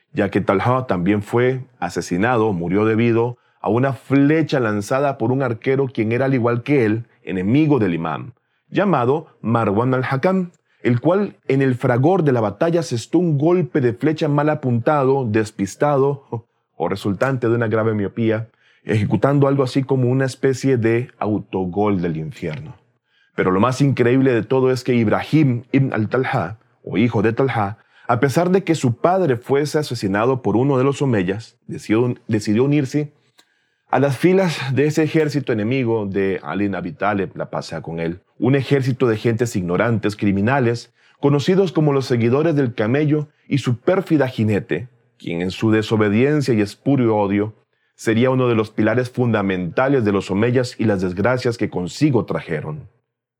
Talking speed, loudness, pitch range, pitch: 160 wpm, -19 LUFS, 110-140 Hz, 120 Hz